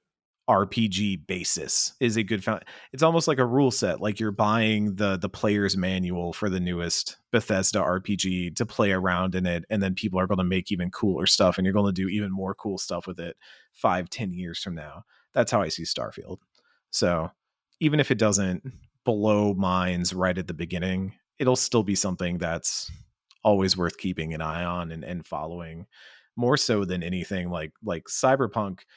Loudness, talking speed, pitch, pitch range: -26 LUFS, 190 wpm, 95 Hz, 90-105 Hz